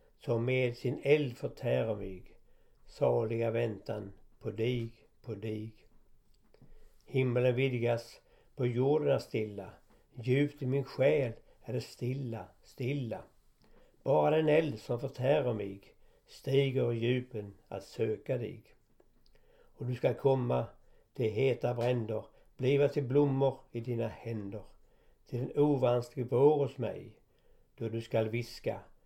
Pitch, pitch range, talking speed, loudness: 120 Hz, 110-135 Hz, 125 wpm, -33 LUFS